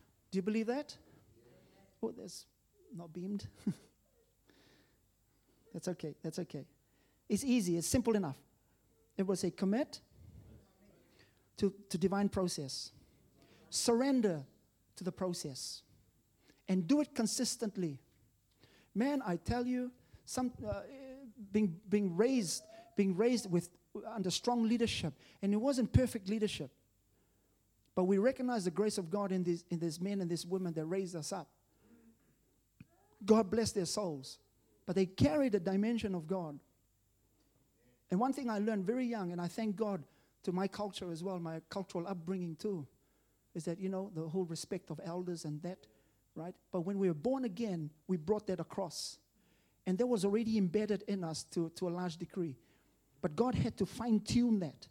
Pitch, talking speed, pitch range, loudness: 185 Hz, 155 wpm, 160-215 Hz, -37 LUFS